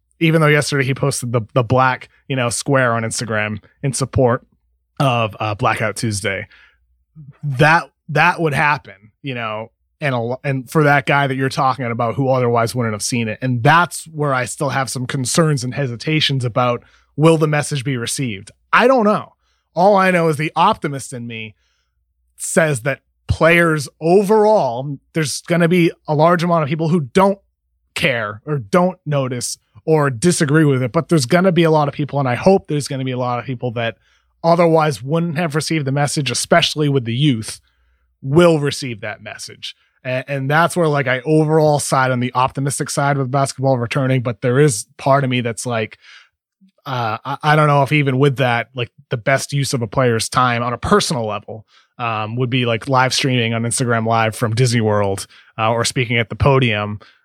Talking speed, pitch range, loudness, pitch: 195 wpm, 120-155 Hz, -17 LUFS, 135 Hz